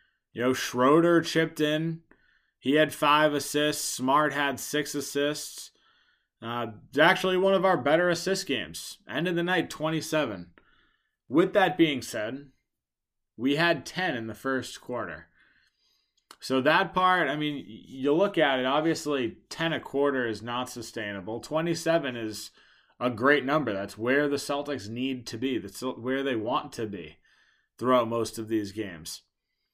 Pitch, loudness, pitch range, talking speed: 140 Hz, -27 LUFS, 120-155 Hz, 155 wpm